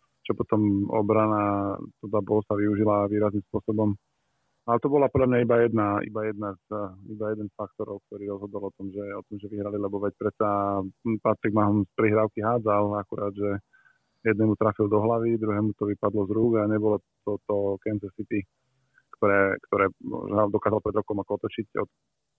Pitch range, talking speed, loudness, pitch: 100-110 Hz, 180 wpm, -26 LUFS, 105 Hz